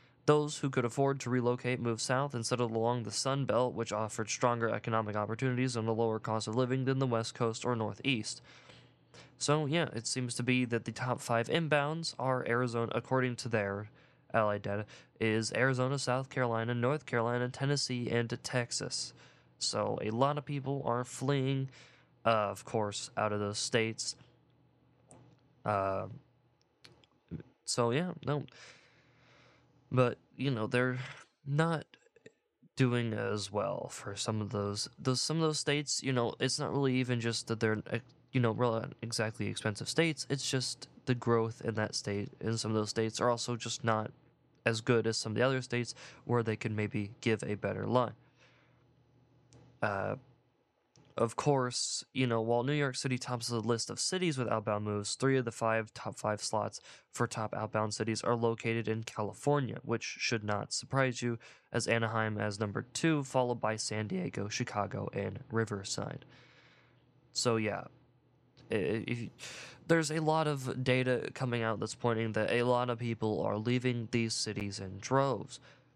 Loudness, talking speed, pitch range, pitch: -34 LUFS, 170 wpm, 110-130 Hz, 120 Hz